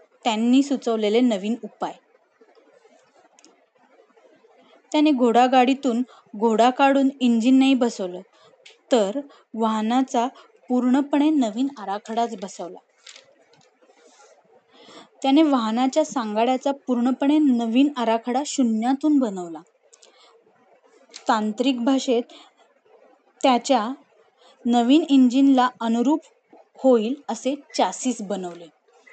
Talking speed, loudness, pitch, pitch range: 70 wpm, -21 LUFS, 255 Hz, 230-275 Hz